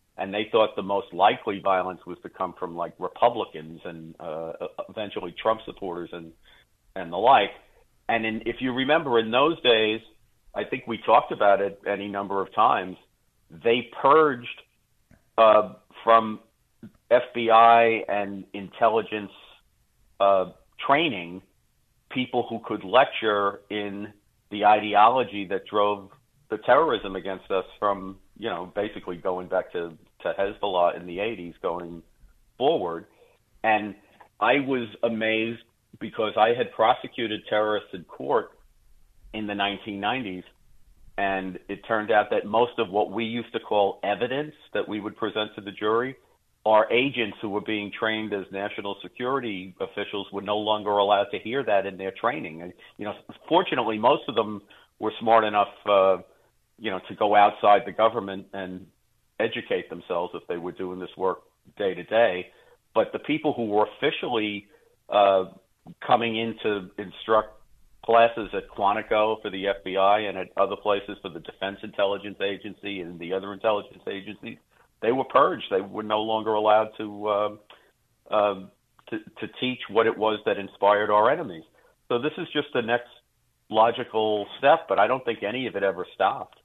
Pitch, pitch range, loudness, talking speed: 105 Hz, 100-115 Hz, -25 LUFS, 160 wpm